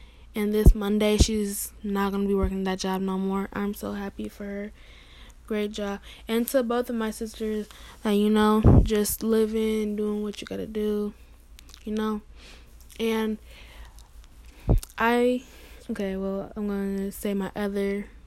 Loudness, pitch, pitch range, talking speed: -26 LUFS, 210 Hz, 195-215 Hz, 165 wpm